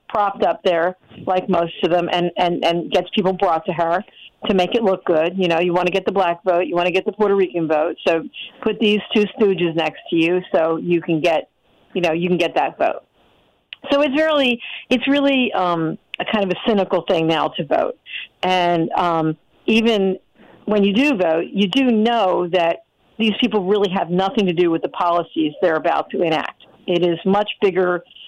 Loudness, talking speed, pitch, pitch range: -19 LUFS, 210 wpm, 185 Hz, 175-210 Hz